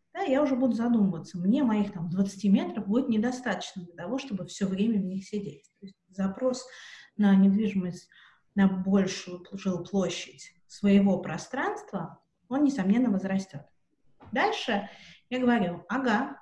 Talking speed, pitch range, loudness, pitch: 135 wpm, 185-235 Hz, -28 LUFS, 200 Hz